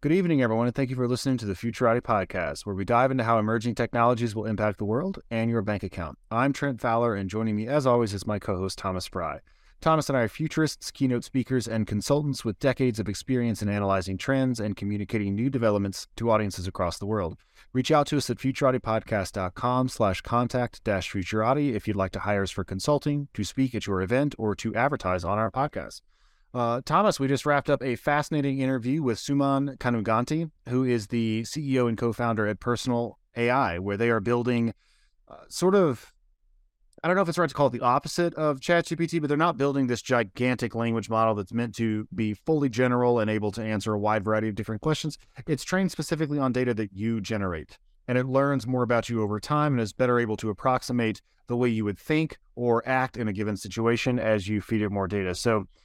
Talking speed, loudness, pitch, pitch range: 210 wpm, -26 LUFS, 120 Hz, 105-135 Hz